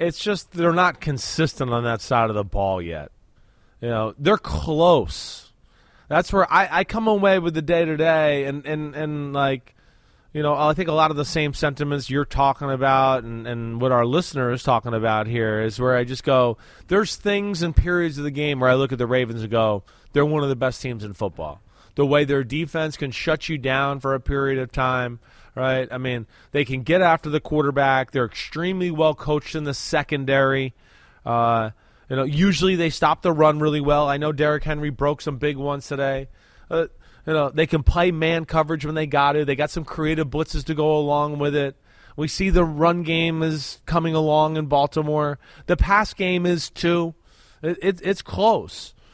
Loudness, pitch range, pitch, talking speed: -22 LUFS, 130-160 Hz, 145 Hz, 205 wpm